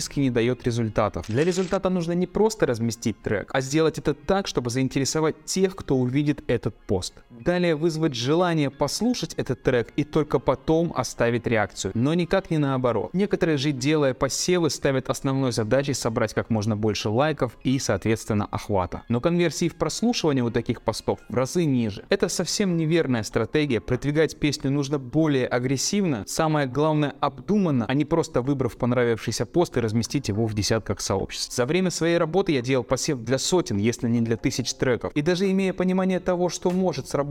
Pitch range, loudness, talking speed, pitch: 120-165 Hz, -24 LUFS, 170 wpm, 140 Hz